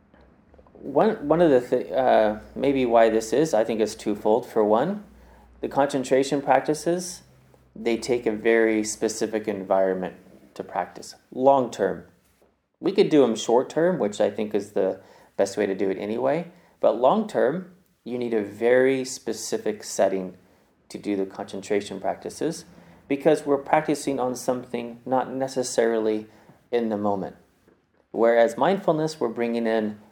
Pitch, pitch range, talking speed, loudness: 115 Hz, 105-135 Hz, 150 wpm, -24 LUFS